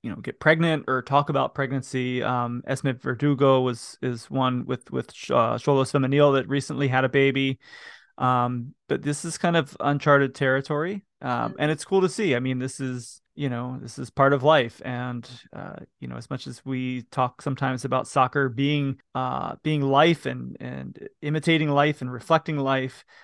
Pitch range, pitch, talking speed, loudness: 125-145 Hz, 135 Hz, 185 wpm, -24 LUFS